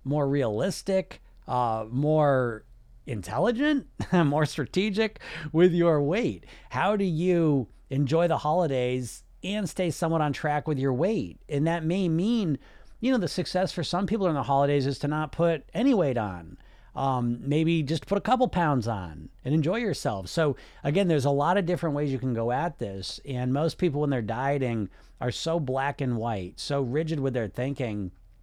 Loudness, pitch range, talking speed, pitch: -27 LUFS, 125-175 Hz, 180 wpm, 150 Hz